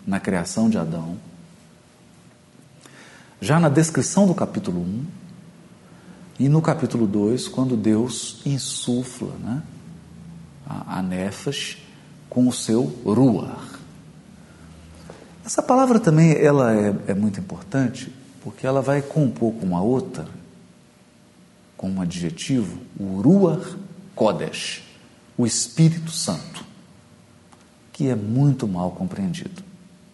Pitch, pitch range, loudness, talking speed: 140 Hz, 115-180 Hz, -22 LUFS, 105 wpm